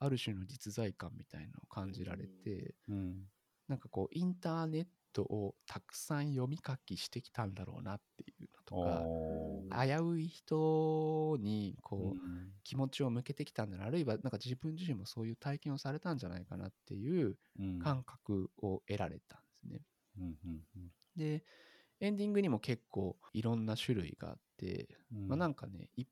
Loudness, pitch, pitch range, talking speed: -40 LUFS, 120 Hz, 95-145 Hz, 335 characters per minute